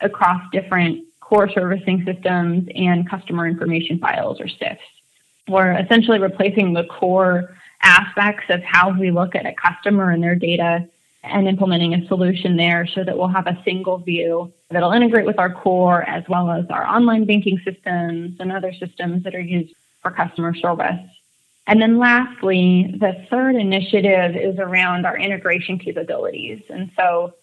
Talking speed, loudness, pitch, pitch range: 160 wpm, -18 LUFS, 185 Hz, 175-195 Hz